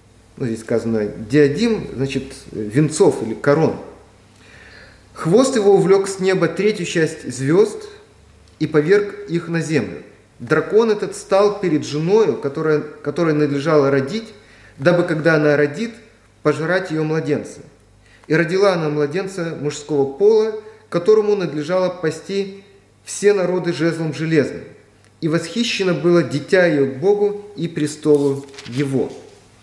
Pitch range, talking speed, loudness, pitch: 140-195 Hz, 120 wpm, -18 LUFS, 160 Hz